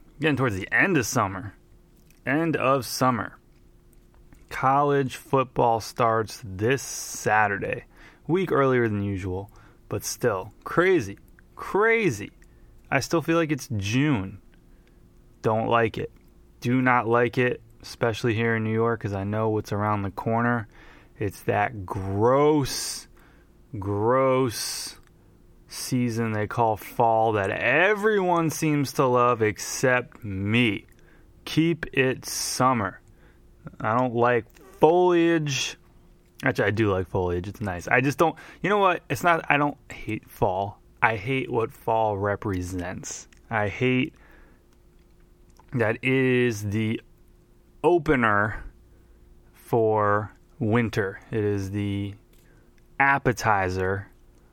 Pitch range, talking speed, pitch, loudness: 105-130 Hz, 115 wpm, 115 Hz, -24 LUFS